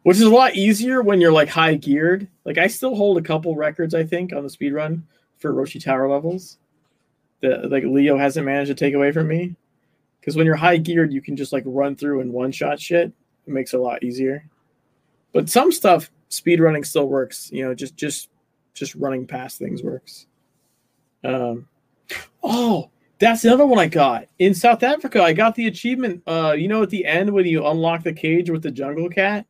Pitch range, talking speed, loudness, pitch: 140-180 Hz, 205 wpm, -19 LUFS, 160 Hz